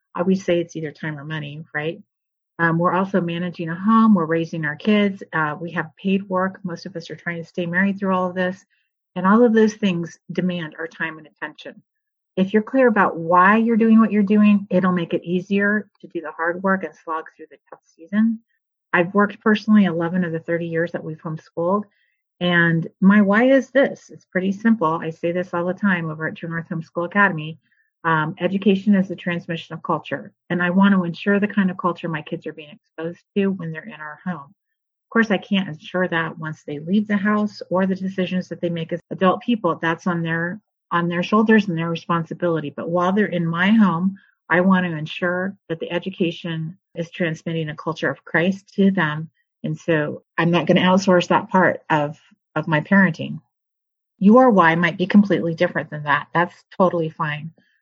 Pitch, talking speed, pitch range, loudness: 175 Hz, 210 wpm, 165-195 Hz, -20 LUFS